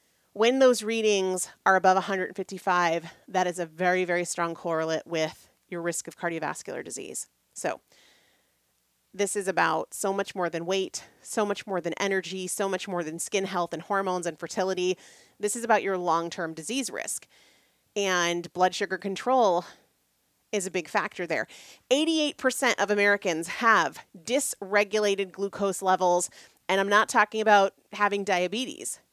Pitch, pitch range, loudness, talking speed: 190 Hz, 175-205 Hz, -27 LUFS, 150 wpm